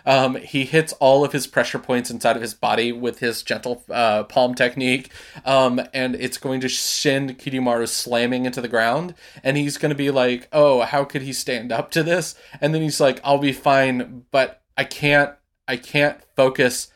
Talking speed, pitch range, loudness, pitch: 200 wpm, 125-145 Hz, -20 LUFS, 130 Hz